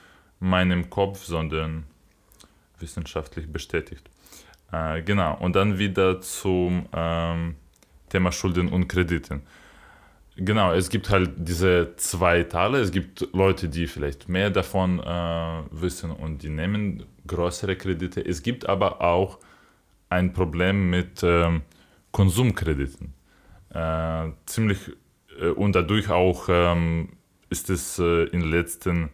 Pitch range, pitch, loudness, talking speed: 80-95 Hz, 90 Hz, -24 LUFS, 120 wpm